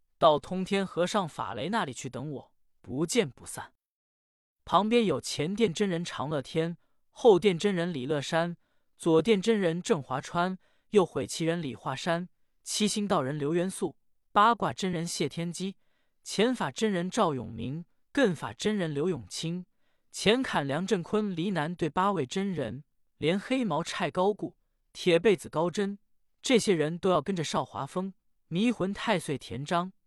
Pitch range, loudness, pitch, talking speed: 145-205 Hz, -29 LUFS, 175 Hz, 225 characters per minute